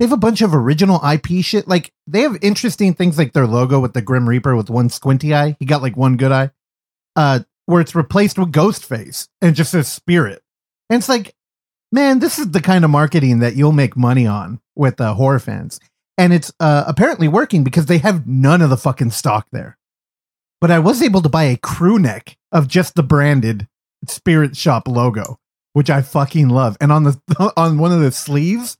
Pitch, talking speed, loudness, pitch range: 150 Hz, 215 wpm, -15 LUFS, 130-180 Hz